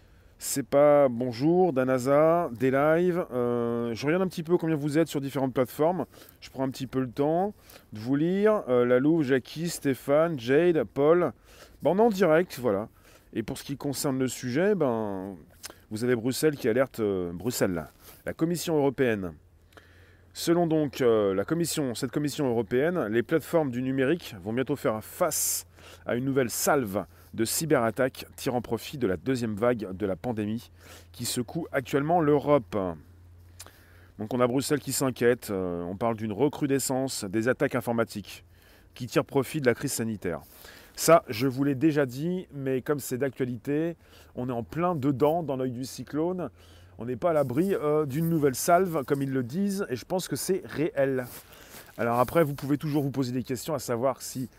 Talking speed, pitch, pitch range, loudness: 180 wpm, 130 Hz, 110-150 Hz, -27 LUFS